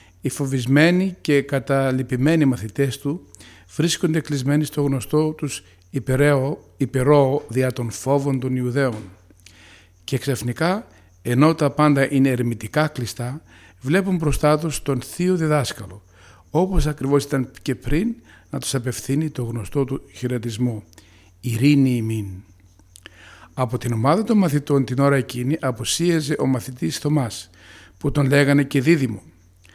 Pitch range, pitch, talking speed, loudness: 110-145 Hz, 135 Hz, 125 wpm, -21 LUFS